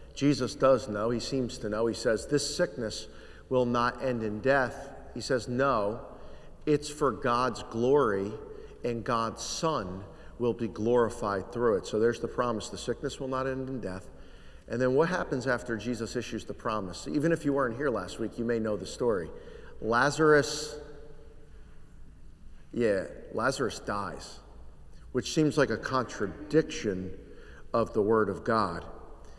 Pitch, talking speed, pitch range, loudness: 120 Hz, 155 wpm, 110-145 Hz, -30 LUFS